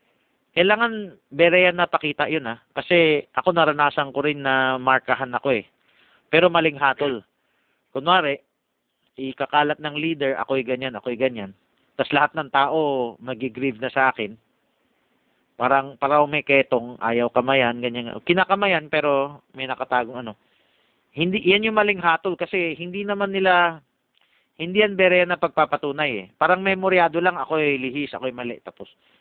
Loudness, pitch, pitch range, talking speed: -21 LUFS, 145 Hz, 130-170 Hz, 140 wpm